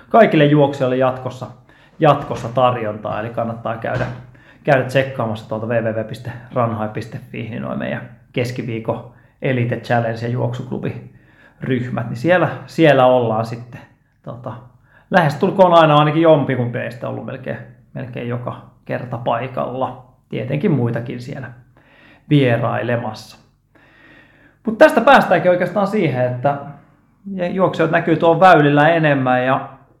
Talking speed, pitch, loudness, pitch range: 105 wpm, 130 Hz, -17 LUFS, 120-150 Hz